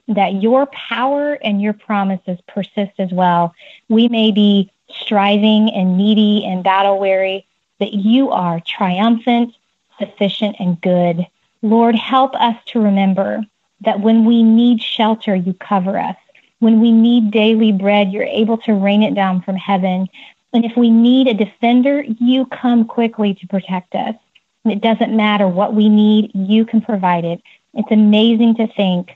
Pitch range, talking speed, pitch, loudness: 195-230 Hz, 160 wpm, 215 Hz, -14 LUFS